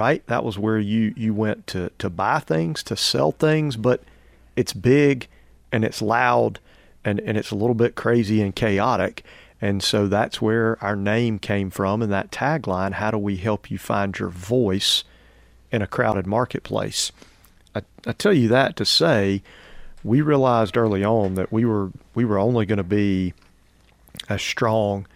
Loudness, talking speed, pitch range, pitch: -22 LUFS, 175 wpm, 95-115 Hz, 105 Hz